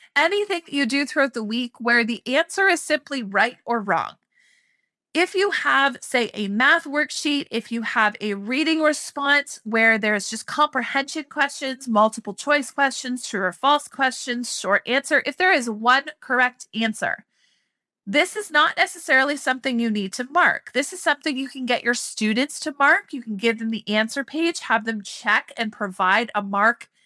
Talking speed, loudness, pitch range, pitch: 180 wpm, -21 LUFS, 225-300 Hz, 265 Hz